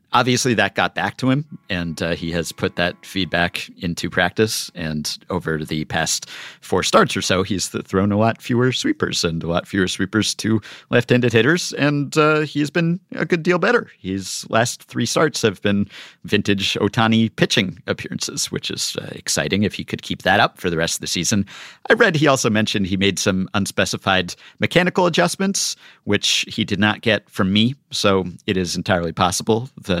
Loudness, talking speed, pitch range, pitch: -19 LUFS, 190 wpm, 95-130 Hz, 105 Hz